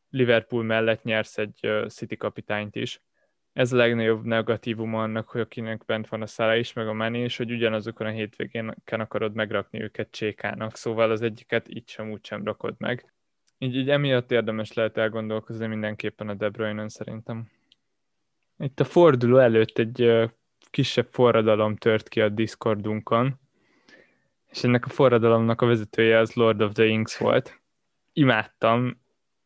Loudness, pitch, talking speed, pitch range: -24 LUFS, 115 Hz, 155 wpm, 110-120 Hz